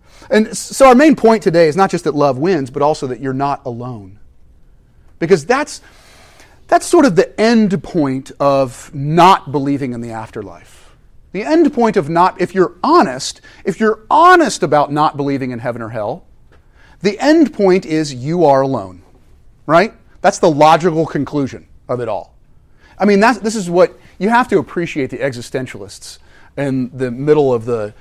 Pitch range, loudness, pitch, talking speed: 130-195 Hz, -14 LUFS, 150 Hz, 175 wpm